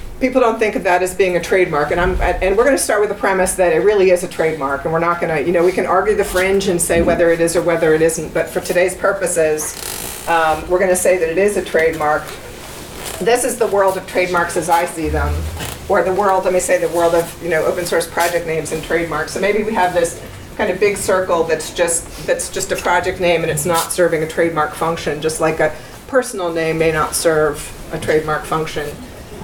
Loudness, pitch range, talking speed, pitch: -16 LUFS, 160-185 Hz, 245 wpm, 175 Hz